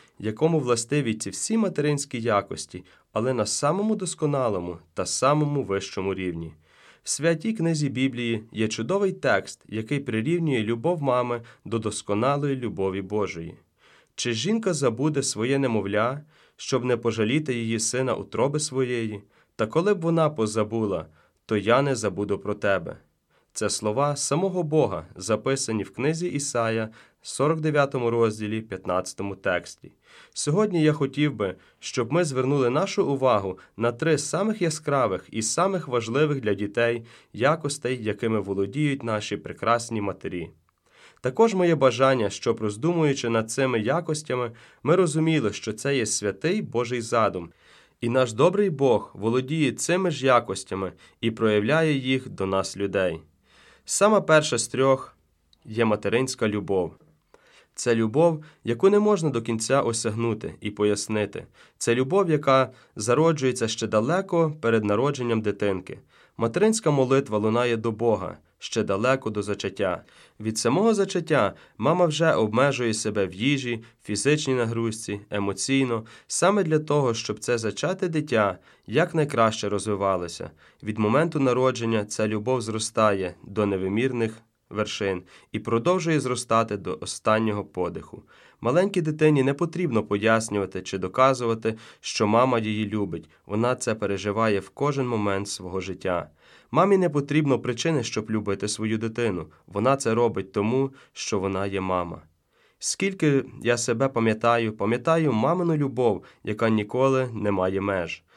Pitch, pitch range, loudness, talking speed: 120 Hz, 105-145 Hz, -25 LUFS, 130 wpm